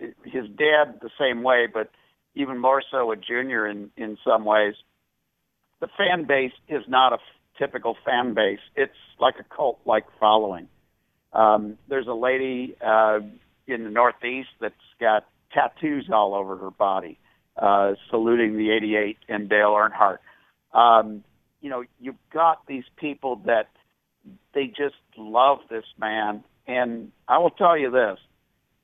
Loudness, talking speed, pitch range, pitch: -23 LUFS, 150 wpm, 105-130 Hz, 120 Hz